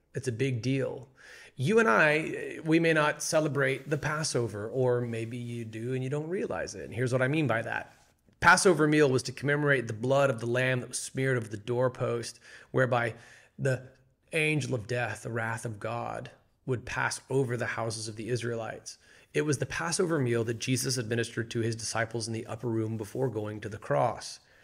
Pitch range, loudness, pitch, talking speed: 115-135 Hz, -29 LUFS, 125 Hz, 200 wpm